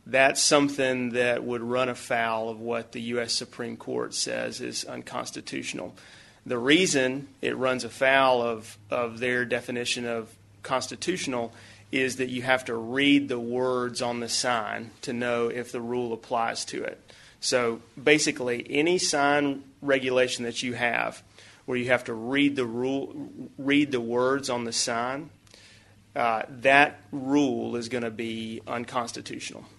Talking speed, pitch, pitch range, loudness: 150 wpm, 125 Hz, 115-135 Hz, -26 LUFS